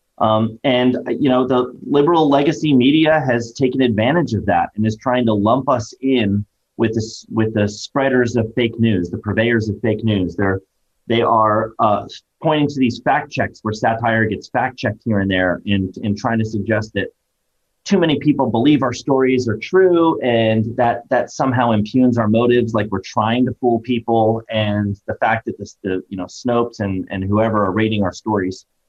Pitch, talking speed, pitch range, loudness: 115 Hz, 195 wpm, 105-125 Hz, -17 LUFS